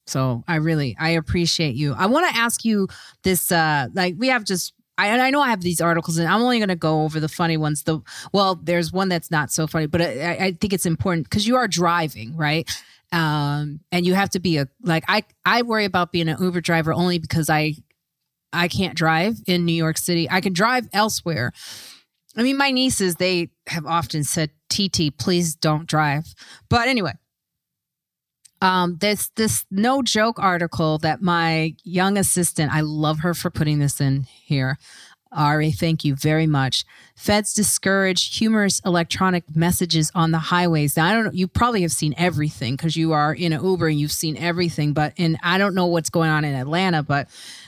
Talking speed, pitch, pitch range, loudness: 200 wpm, 170 Hz, 155-190 Hz, -20 LUFS